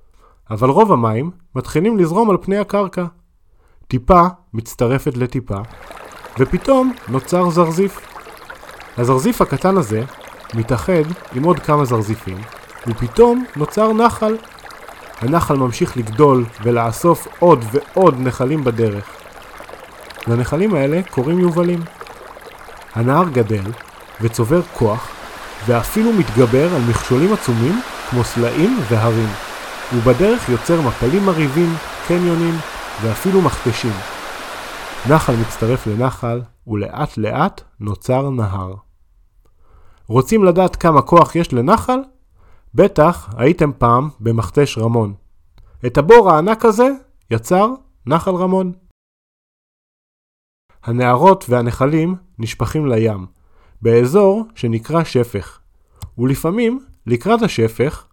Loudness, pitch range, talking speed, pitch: -16 LUFS, 115-175 Hz, 95 wpm, 130 Hz